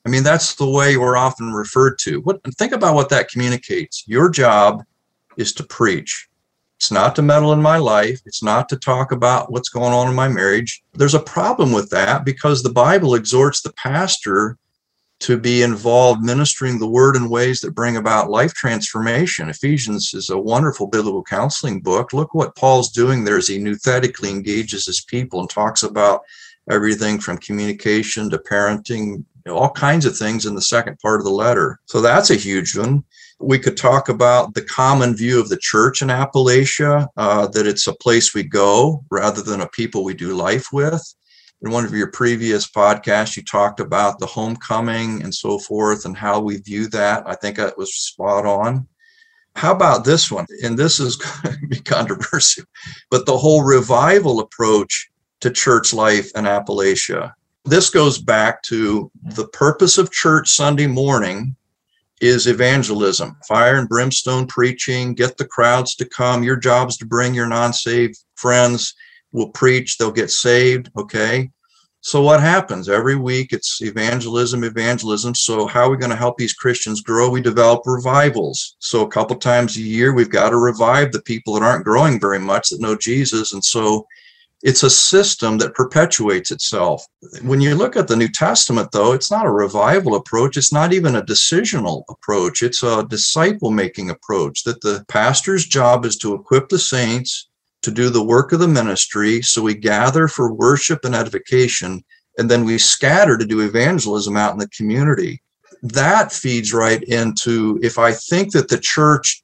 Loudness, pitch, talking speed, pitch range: -16 LUFS, 120 Hz, 180 wpm, 110-135 Hz